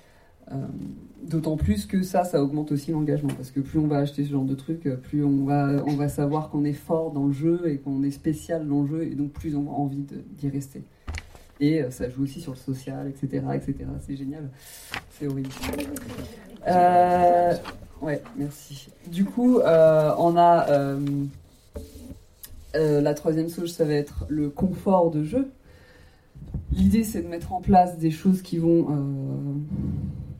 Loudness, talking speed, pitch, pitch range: -24 LUFS, 180 wpm, 145 Hz, 140-165 Hz